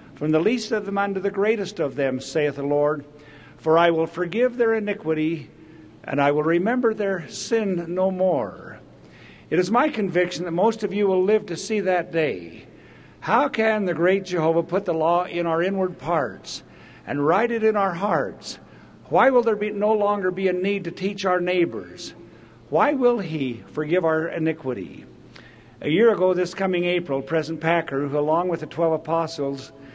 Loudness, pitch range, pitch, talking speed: -22 LUFS, 160-200 Hz, 175 Hz, 185 wpm